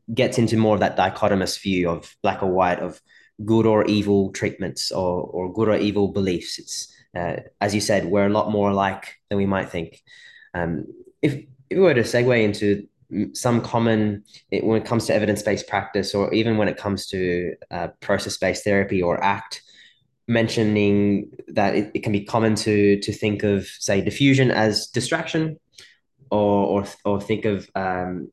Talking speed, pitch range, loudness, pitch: 180 wpm, 100-115 Hz, -22 LUFS, 105 Hz